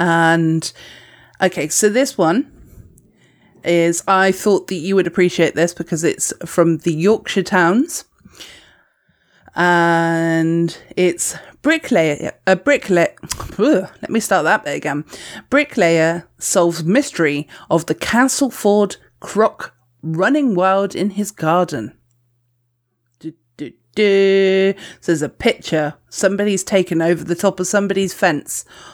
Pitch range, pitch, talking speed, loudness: 160-200 Hz, 175 Hz, 120 wpm, -17 LUFS